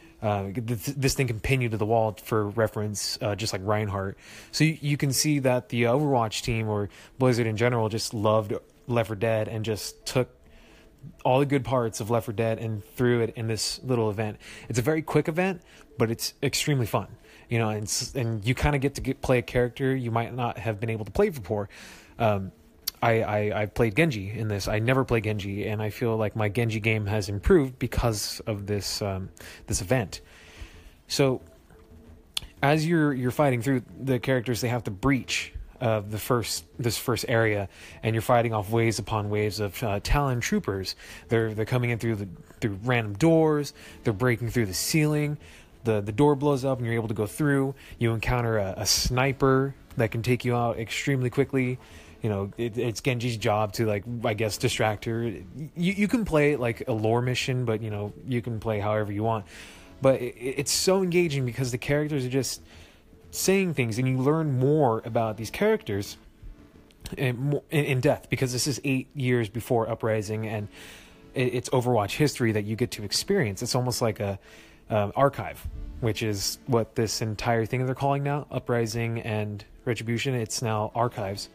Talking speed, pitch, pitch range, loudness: 195 wpm, 115 Hz, 110-130 Hz, -27 LUFS